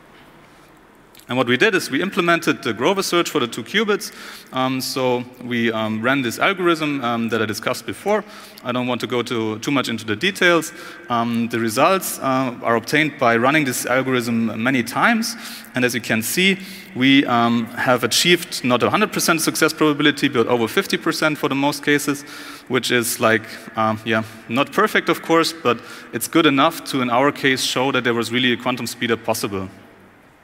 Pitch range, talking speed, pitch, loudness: 115-165 Hz, 185 wpm, 130 Hz, -19 LUFS